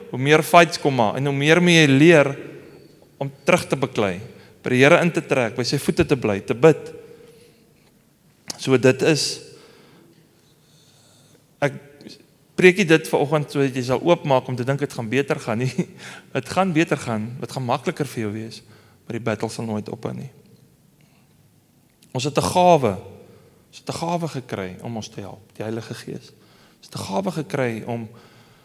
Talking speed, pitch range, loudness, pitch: 180 wpm, 120-160 Hz, -20 LUFS, 140 Hz